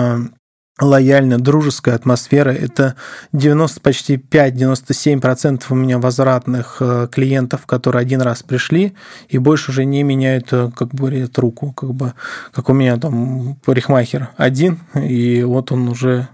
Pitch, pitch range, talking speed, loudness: 130 Hz, 125-140 Hz, 130 wpm, -15 LUFS